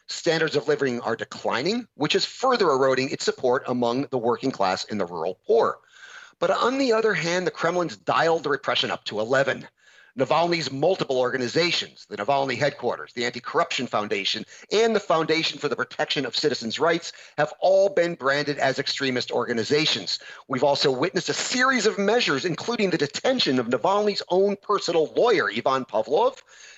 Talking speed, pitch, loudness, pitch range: 170 wpm, 165 Hz, -23 LUFS, 135-215 Hz